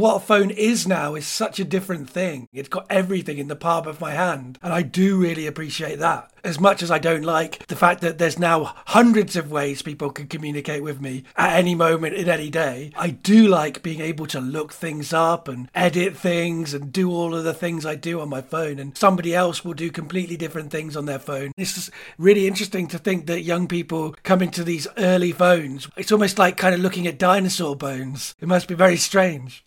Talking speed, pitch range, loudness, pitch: 225 wpm, 155-185 Hz, -21 LUFS, 170 Hz